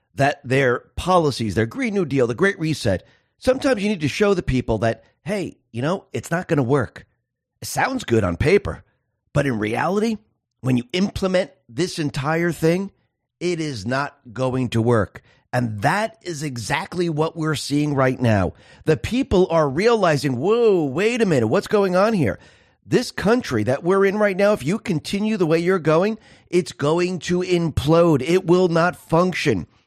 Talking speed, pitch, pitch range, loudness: 175 wpm, 160 Hz, 130-185 Hz, -20 LUFS